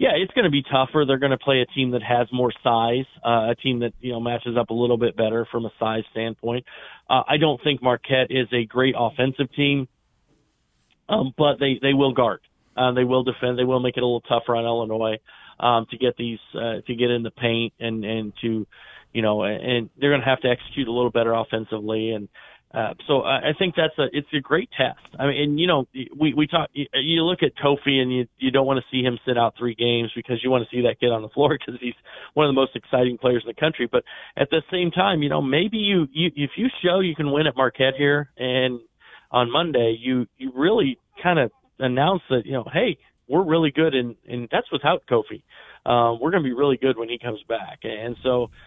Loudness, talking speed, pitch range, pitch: -22 LUFS, 245 wpm, 120-140 Hz, 125 Hz